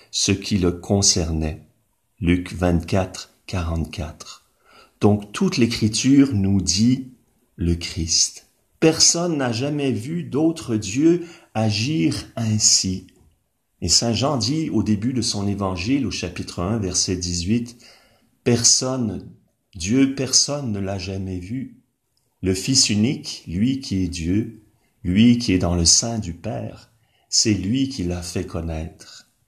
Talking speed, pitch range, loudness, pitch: 130 wpm, 95-125 Hz, -20 LUFS, 110 Hz